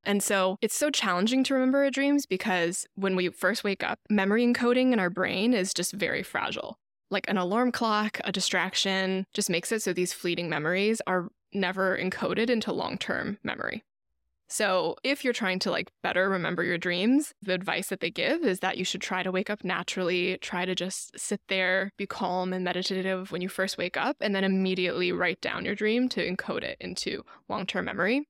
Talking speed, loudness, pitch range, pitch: 205 wpm, -28 LUFS, 185-220 Hz, 190 Hz